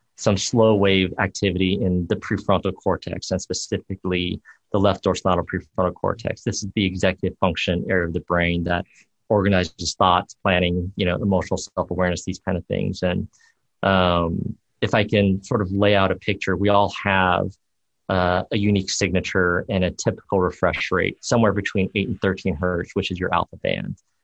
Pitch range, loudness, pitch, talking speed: 90-100 Hz, -22 LUFS, 95 Hz, 175 wpm